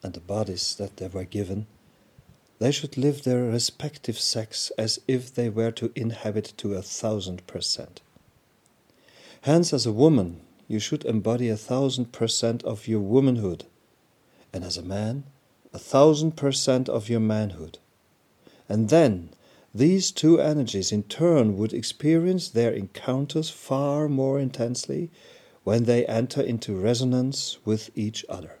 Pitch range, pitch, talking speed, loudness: 105-135 Hz, 115 Hz, 145 wpm, -25 LUFS